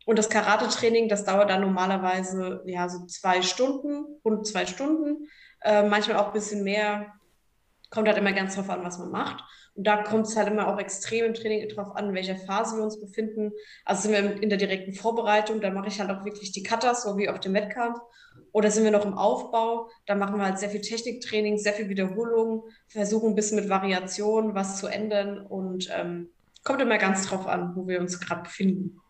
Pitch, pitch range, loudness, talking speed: 205 Hz, 195-220 Hz, -26 LUFS, 210 wpm